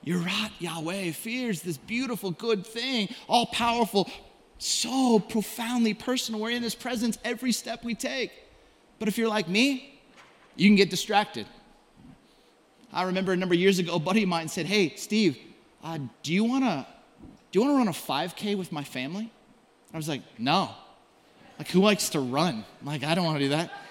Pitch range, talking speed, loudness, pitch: 175-235 Hz, 190 wpm, -27 LUFS, 210 Hz